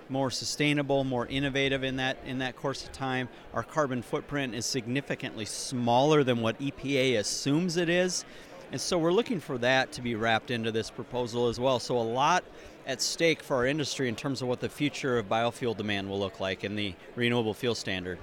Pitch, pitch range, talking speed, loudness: 130 Hz, 120-140 Hz, 205 wpm, -29 LUFS